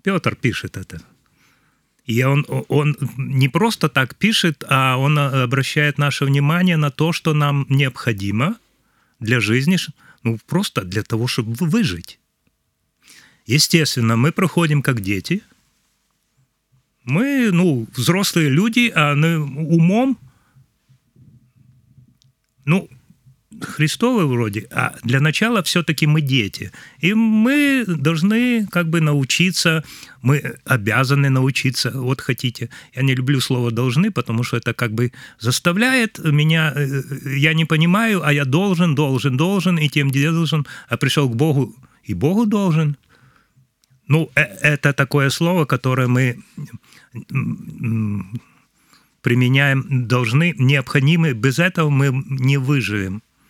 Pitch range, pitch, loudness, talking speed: 130-165 Hz, 140 Hz, -18 LUFS, 120 wpm